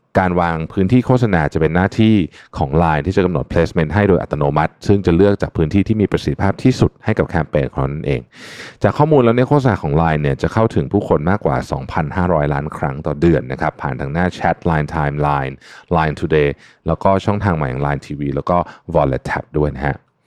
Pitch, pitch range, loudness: 85 Hz, 75-100 Hz, -17 LUFS